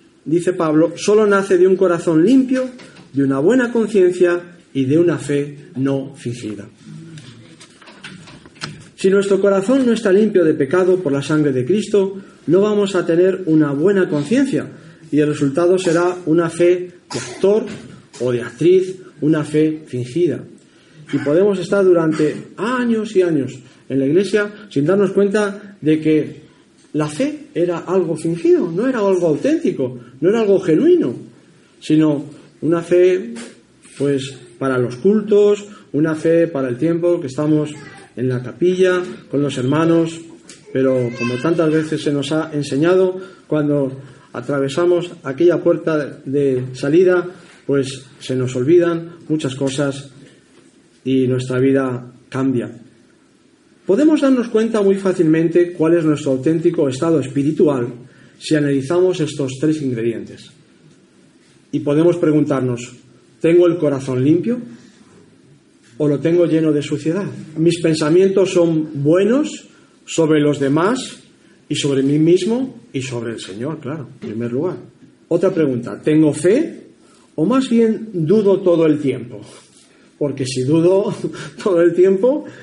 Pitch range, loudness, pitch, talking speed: 140-185 Hz, -17 LUFS, 160 Hz, 135 wpm